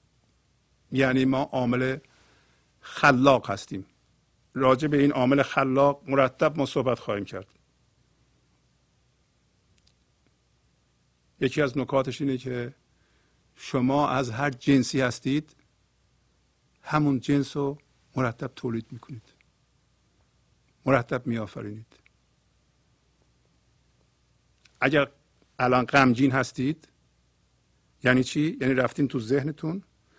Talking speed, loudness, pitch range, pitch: 85 wpm, -25 LUFS, 120-140 Hz, 130 Hz